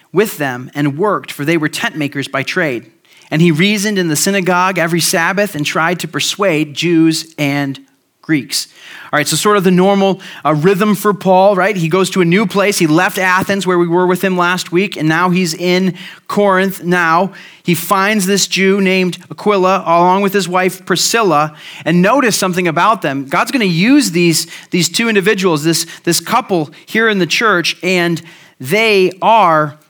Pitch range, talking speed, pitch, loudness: 165-195 Hz, 190 wpm, 180 Hz, -13 LUFS